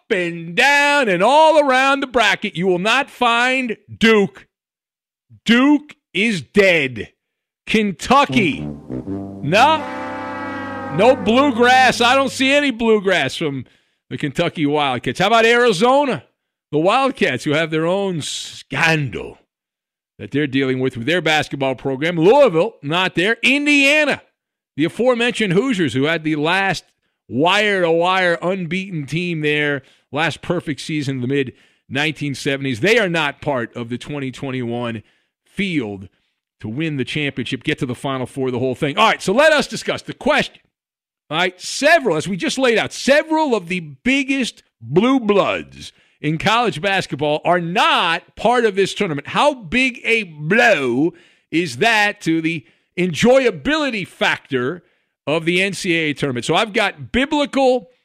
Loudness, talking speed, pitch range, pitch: -17 LUFS, 145 wpm, 145-235 Hz, 180 Hz